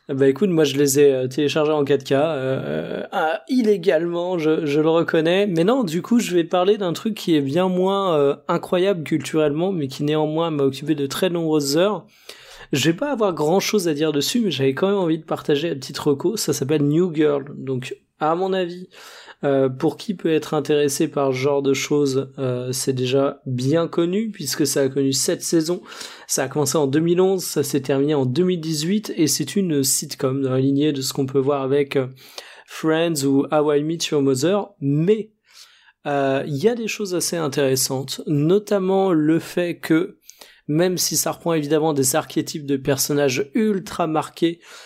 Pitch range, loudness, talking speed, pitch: 140-180 Hz, -20 LUFS, 195 wpm, 155 Hz